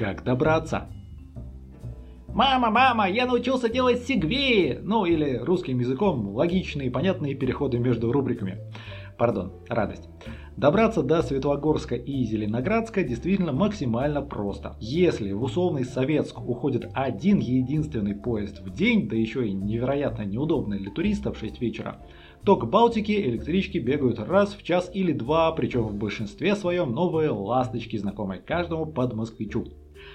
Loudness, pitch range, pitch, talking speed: -25 LUFS, 105-170 Hz, 125 Hz, 130 wpm